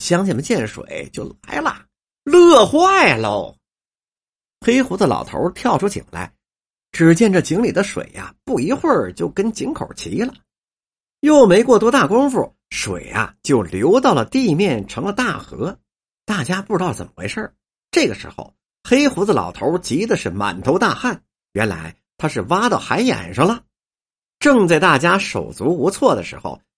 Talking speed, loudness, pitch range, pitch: 235 characters per minute, -17 LUFS, 175-265 Hz, 200 Hz